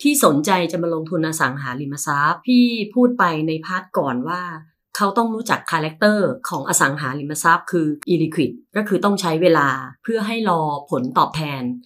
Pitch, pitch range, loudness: 170 Hz, 150-205 Hz, -19 LUFS